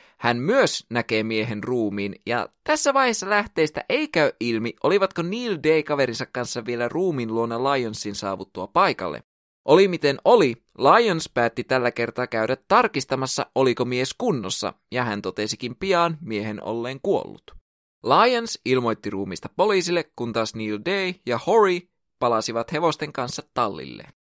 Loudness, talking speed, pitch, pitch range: -23 LUFS, 140 wpm, 125 Hz, 110-165 Hz